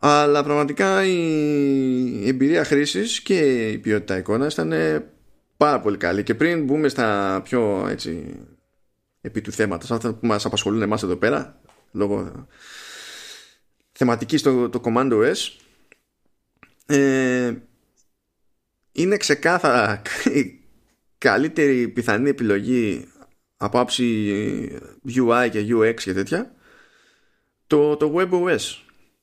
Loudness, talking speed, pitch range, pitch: -21 LUFS, 105 wpm, 105-145 Hz, 125 Hz